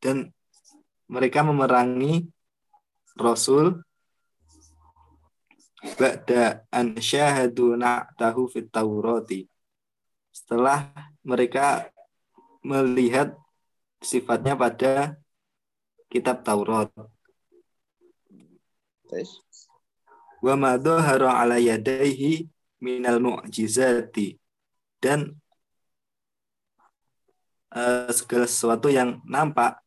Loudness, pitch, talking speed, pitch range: -23 LUFS, 130 Hz, 60 wpm, 120-150 Hz